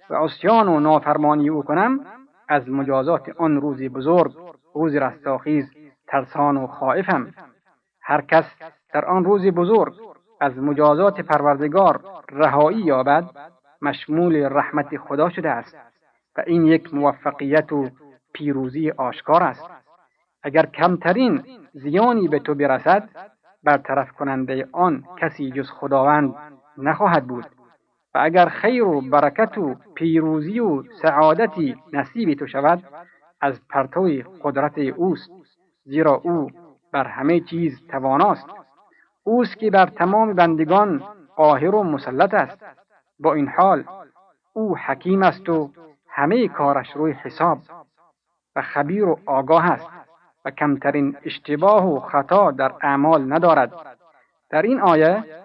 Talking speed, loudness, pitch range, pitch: 120 wpm, -19 LUFS, 140-175 Hz, 150 Hz